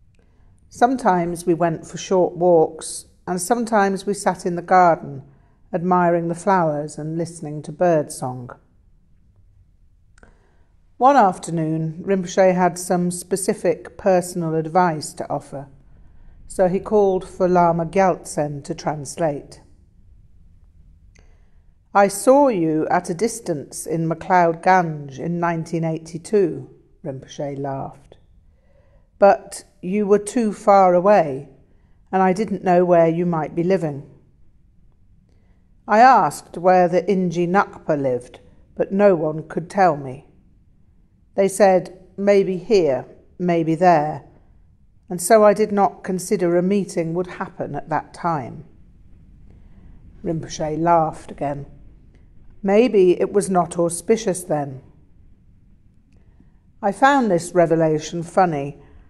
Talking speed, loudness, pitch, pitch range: 115 wpm, -19 LUFS, 170 Hz, 135-185 Hz